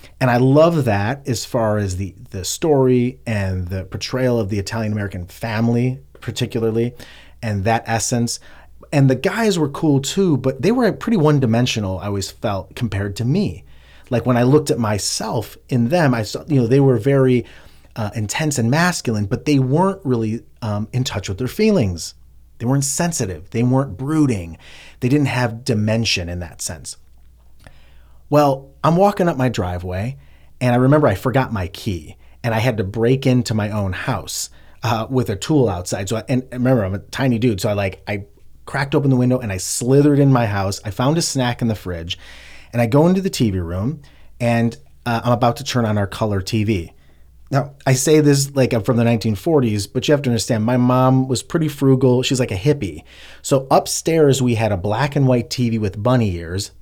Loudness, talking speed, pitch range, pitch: -18 LUFS, 200 wpm, 100-135 Hz, 120 Hz